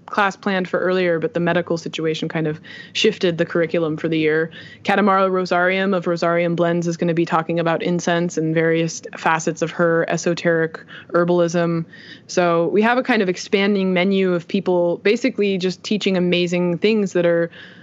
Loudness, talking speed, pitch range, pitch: -19 LUFS, 175 wpm, 170-190 Hz, 175 Hz